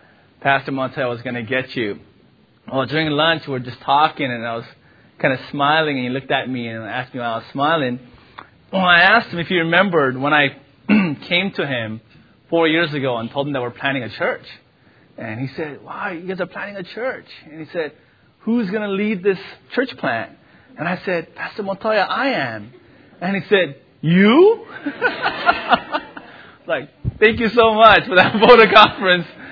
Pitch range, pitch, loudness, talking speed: 130-200 Hz, 160 Hz, -17 LUFS, 195 wpm